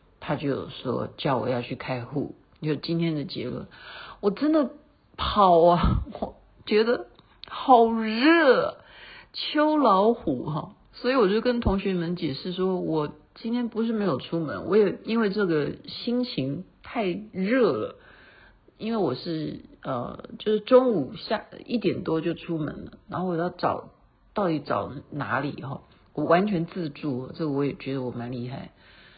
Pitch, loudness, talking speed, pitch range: 185 Hz, -26 LUFS, 215 characters per minute, 150-230 Hz